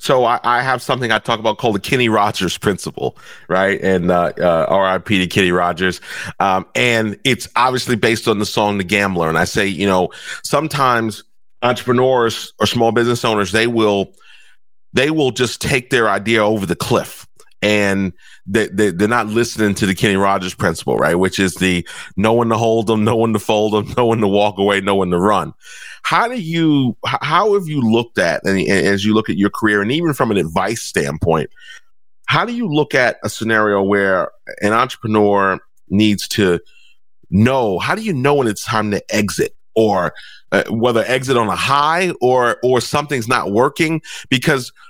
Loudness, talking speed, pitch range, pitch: -16 LUFS, 190 wpm, 100-125 Hz, 110 Hz